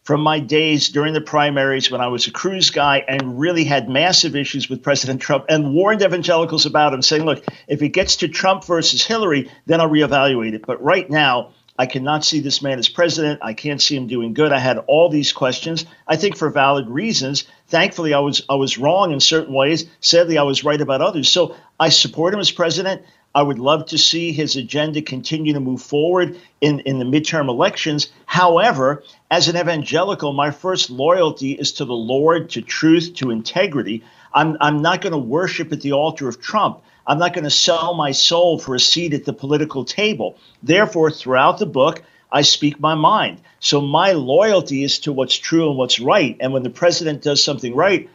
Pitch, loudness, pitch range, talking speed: 150 Hz, -16 LUFS, 135-165 Hz, 205 wpm